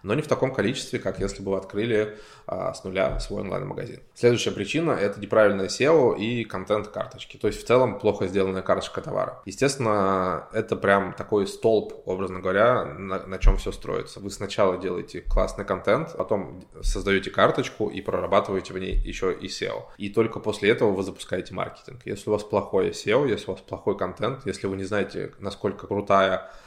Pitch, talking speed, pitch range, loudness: 100 Hz, 180 wpm, 95-105 Hz, -25 LUFS